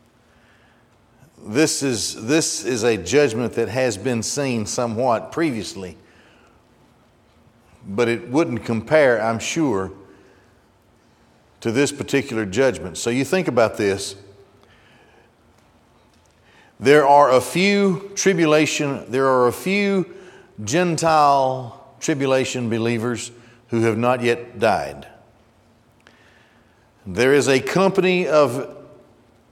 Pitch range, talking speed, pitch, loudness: 115-145 Hz, 100 wpm, 120 Hz, -19 LUFS